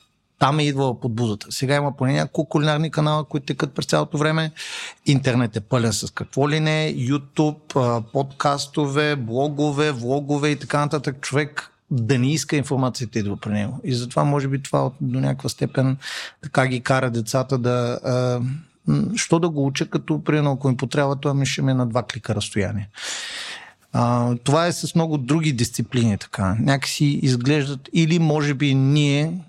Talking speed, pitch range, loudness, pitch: 165 wpm, 125-150 Hz, -22 LUFS, 140 Hz